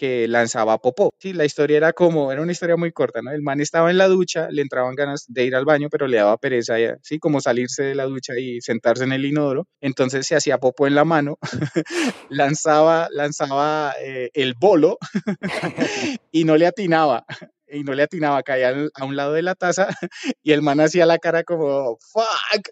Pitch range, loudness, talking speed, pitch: 135-165 Hz, -20 LUFS, 210 wpm, 150 Hz